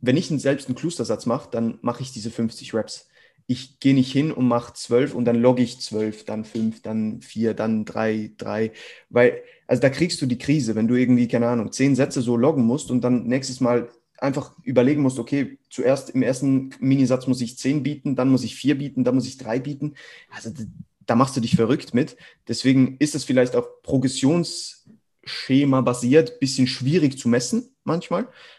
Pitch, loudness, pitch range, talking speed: 130 Hz, -22 LUFS, 120-140 Hz, 195 wpm